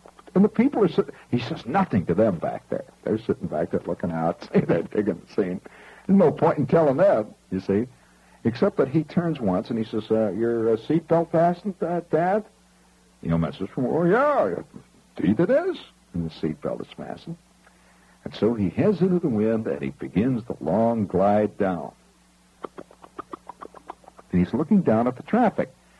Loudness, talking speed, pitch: -24 LUFS, 185 wpm, 115 Hz